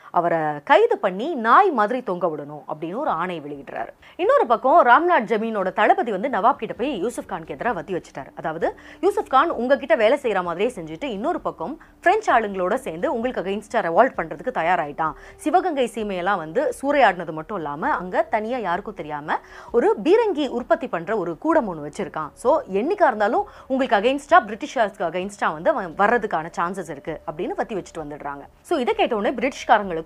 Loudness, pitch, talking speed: -21 LUFS, 220 Hz, 160 wpm